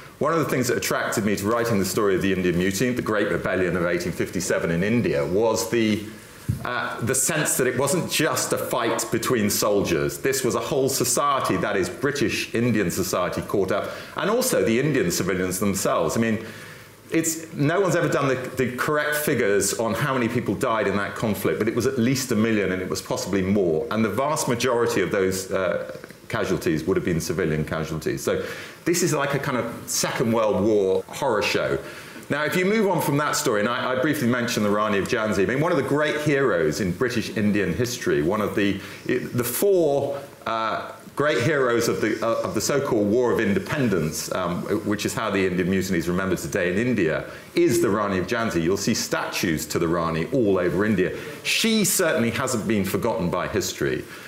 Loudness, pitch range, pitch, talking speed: -23 LUFS, 105-150 Hz, 120 Hz, 205 wpm